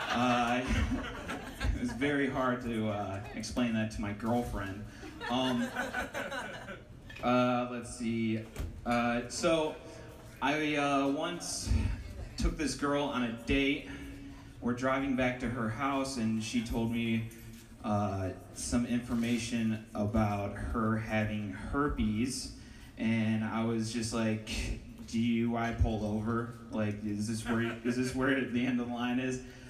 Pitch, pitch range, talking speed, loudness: 115 Hz, 110-125 Hz, 135 wpm, -33 LUFS